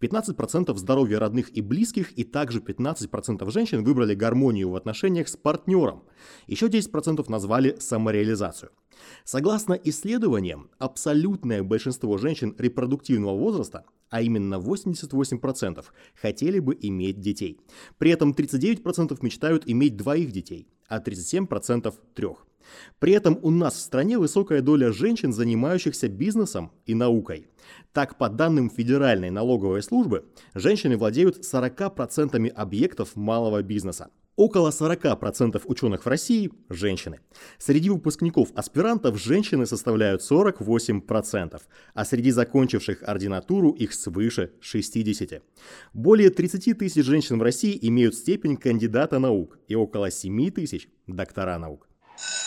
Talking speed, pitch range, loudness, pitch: 115 wpm, 110-160 Hz, -24 LUFS, 125 Hz